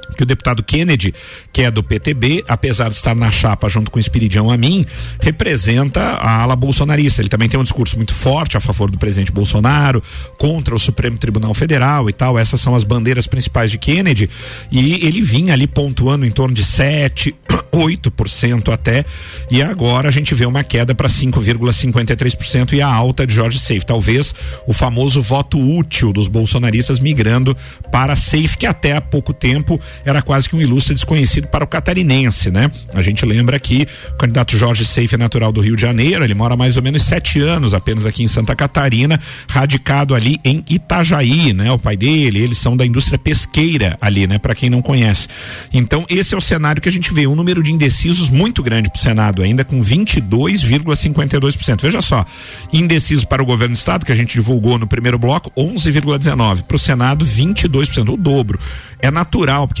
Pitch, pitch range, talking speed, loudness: 125 Hz, 115-145 Hz, 195 wpm, -14 LUFS